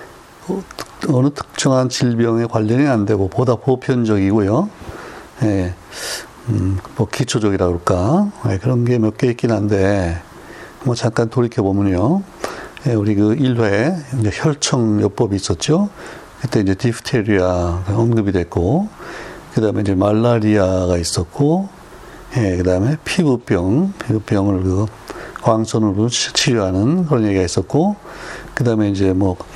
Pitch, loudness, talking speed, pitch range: 115 Hz, -17 LUFS, 270 characters per minute, 100-130 Hz